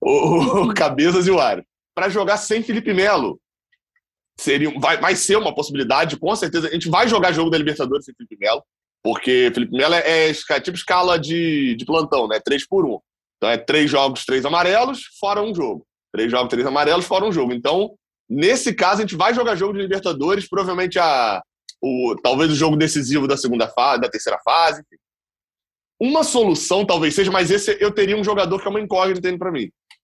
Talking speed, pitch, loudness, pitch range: 195 wpm, 180 Hz, -18 LUFS, 150-210 Hz